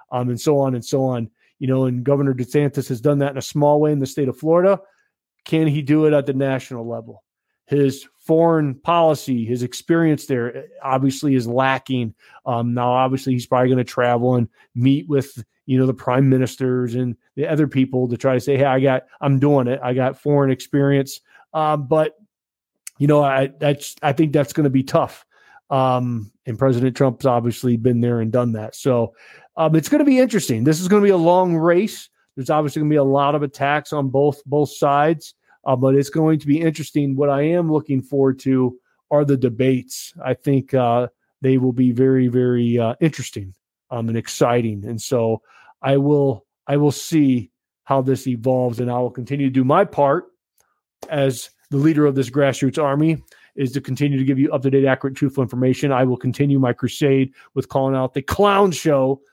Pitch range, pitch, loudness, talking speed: 125-145 Hz, 135 Hz, -19 LUFS, 205 wpm